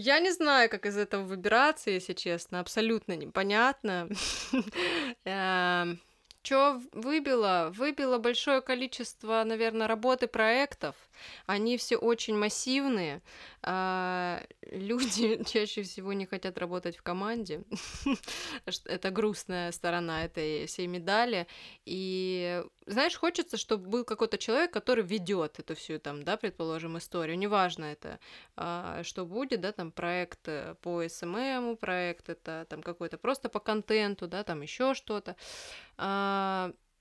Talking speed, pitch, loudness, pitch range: 120 wpm, 205 Hz, -31 LUFS, 180-235 Hz